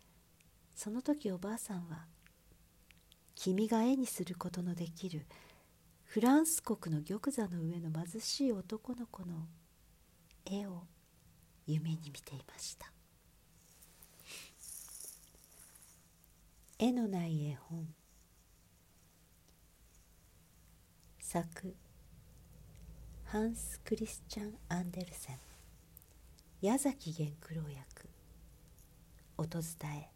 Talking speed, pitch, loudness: 160 characters per minute, 160 Hz, -39 LUFS